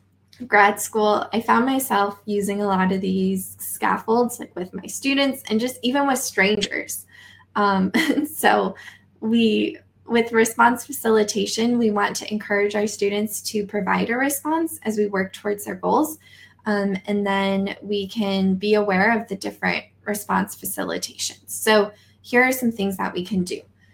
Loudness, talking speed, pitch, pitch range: -21 LUFS, 160 wpm, 210 Hz, 200-230 Hz